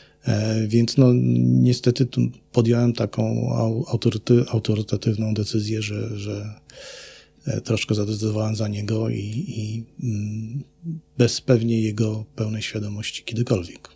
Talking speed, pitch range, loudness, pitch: 100 wpm, 105-120 Hz, -23 LUFS, 110 Hz